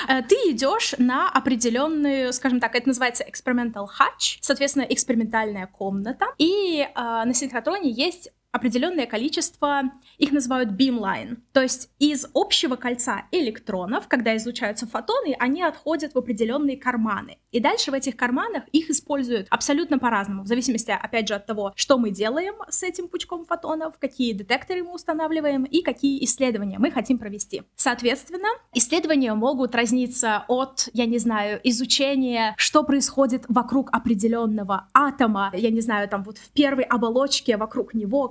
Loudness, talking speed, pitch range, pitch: -22 LUFS, 145 wpm, 230-285 Hz, 255 Hz